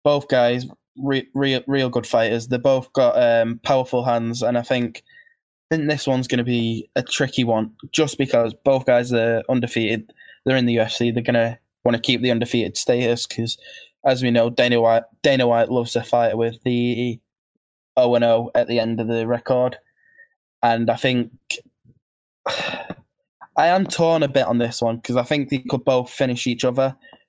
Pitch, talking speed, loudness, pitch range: 120 Hz, 185 wpm, -20 LUFS, 115-135 Hz